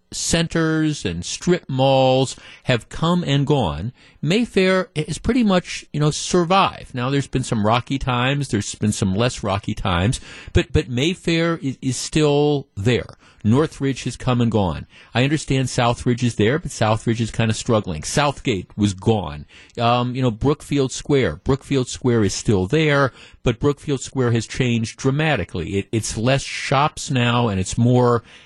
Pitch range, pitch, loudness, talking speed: 115-145 Hz, 125 Hz, -20 LUFS, 160 wpm